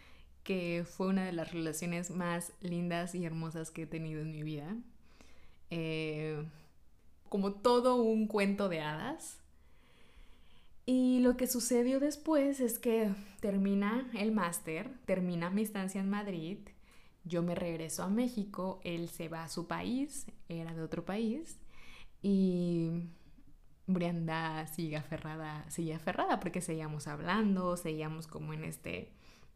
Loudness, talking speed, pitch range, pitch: -36 LUFS, 135 wpm, 160-205 Hz, 175 Hz